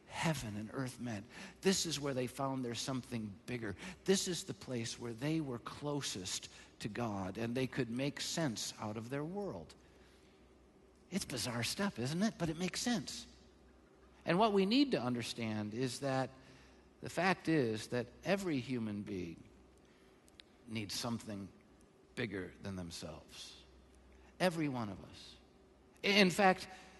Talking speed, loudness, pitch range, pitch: 145 wpm, -38 LUFS, 110-165 Hz, 125 Hz